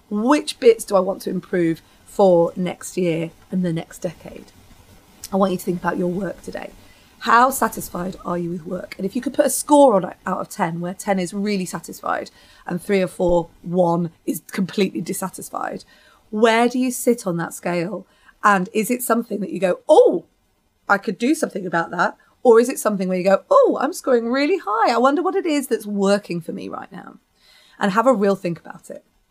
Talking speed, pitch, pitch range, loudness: 215 wpm, 200 Hz, 180-240 Hz, -20 LUFS